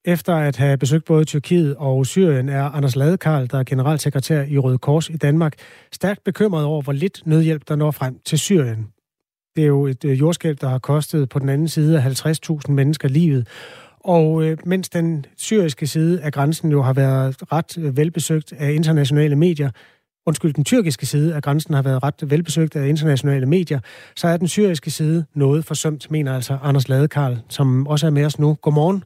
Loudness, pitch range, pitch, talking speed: -19 LUFS, 140-160 Hz, 150 Hz, 190 wpm